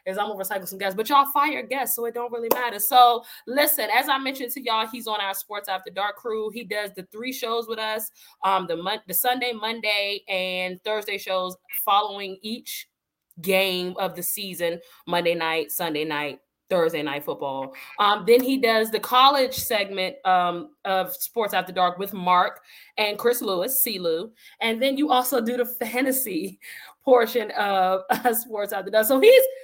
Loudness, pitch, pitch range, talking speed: -23 LUFS, 215 Hz, 190-245 Hz, 185 wpm